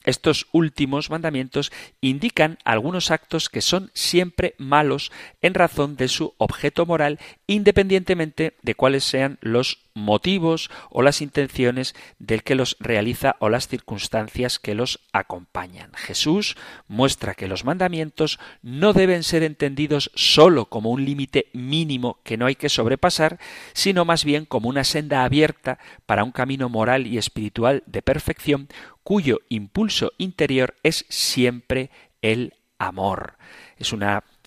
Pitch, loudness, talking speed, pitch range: 140 Hz, -21 LUFS, 135 wpm, 120-160 Hz